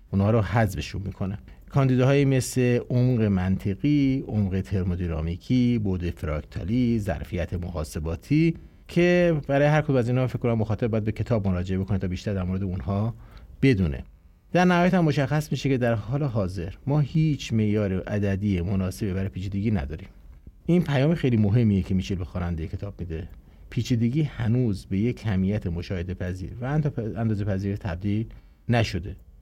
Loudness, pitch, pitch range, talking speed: -25 LUFS, 105 Hz, 95-125 Hz, 150 wpm